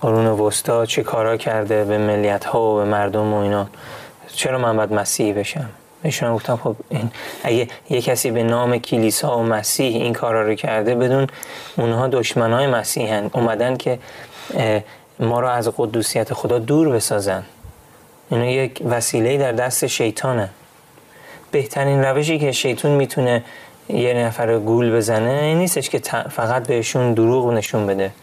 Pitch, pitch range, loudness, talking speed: 115 Hz, 110-125 Hz, -19 LUFS, 155 wpm